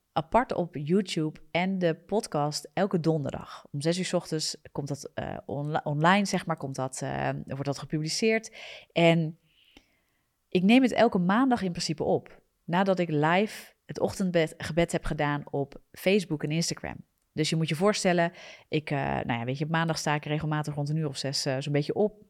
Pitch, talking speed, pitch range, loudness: 160 Hz, 190 wpm, 150-185 Hz, -28 LUFS